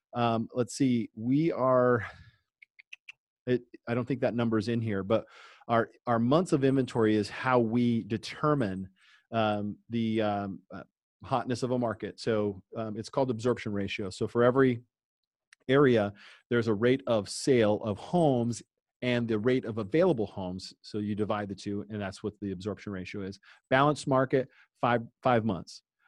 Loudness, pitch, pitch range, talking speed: -29 LUFS, 115 Hz, 105-125 Hz, 165 wpm